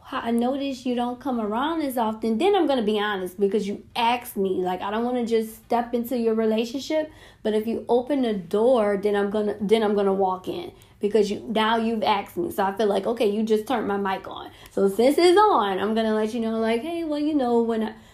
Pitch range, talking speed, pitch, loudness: 205-245 Hz, 240 wpm, 225 Hz, -23 LUFS